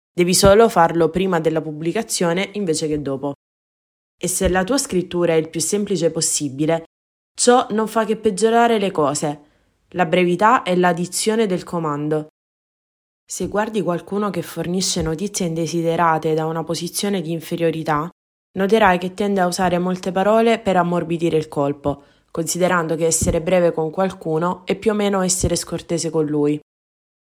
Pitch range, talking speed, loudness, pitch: 160-195 Hz, 150 wpm, -19 LUFS, 175 Hz